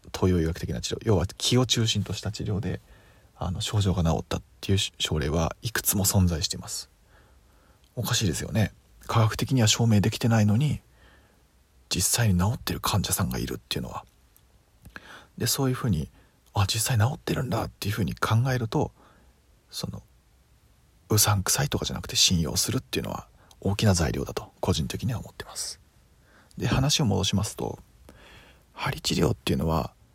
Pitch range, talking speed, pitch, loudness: 85-110 Hz, 345 characters per minute, 100 Hz, -26 LUFS